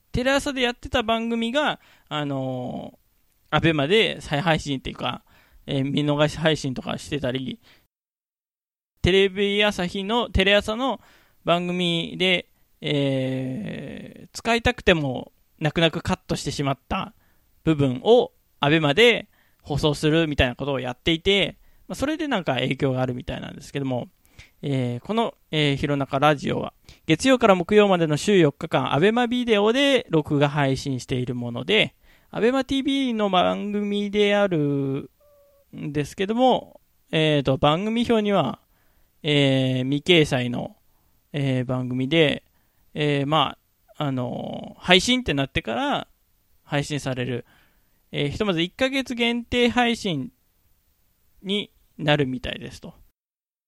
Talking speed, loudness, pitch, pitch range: 275 characters per minute, -22 LUFS, 155 Hz, 135-210 Hz